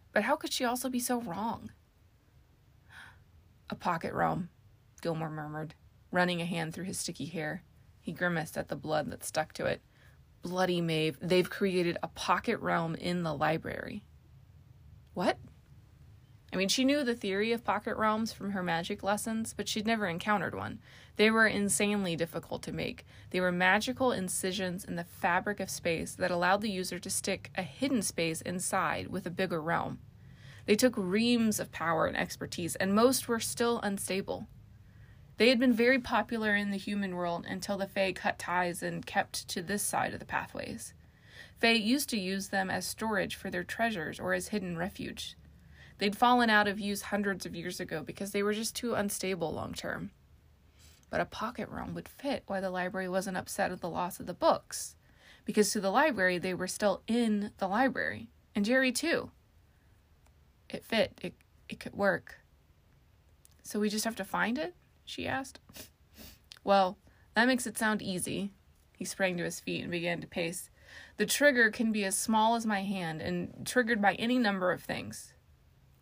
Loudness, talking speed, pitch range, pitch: -32 LUFS, 180 wpm, 170-220 Hz, 195 Hz